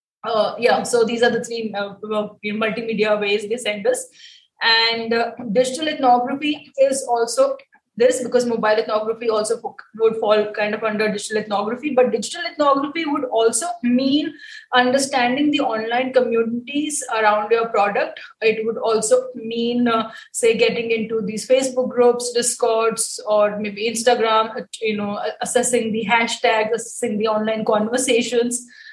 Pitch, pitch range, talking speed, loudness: 235 Hz, 220-255 Hz, 145 wpm, -19 LUFS